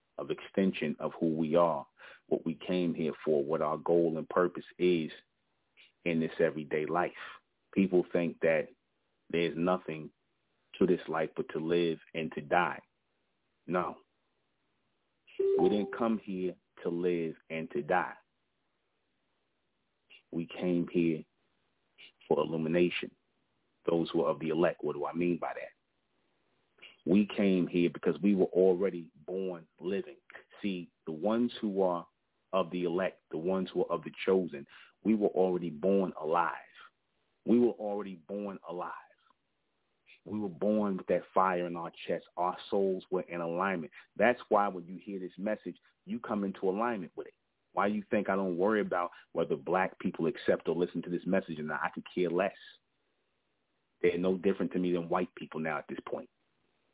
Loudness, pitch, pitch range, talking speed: -32 LUFS, 90 Hz, 85-100 Hz, 165 wpm